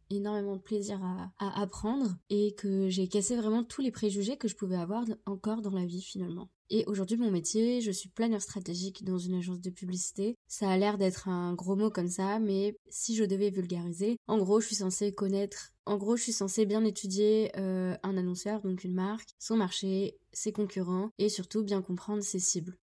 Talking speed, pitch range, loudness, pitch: 210 wpm, 185-215 Hz, -32 LUFS, 200 Hz